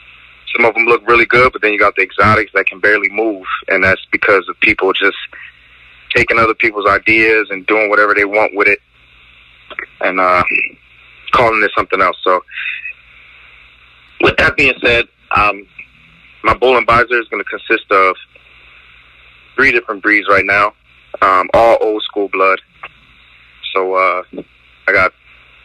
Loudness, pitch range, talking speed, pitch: -12 LUFS, 60-105 Hz, 155 wpm, 95 Hz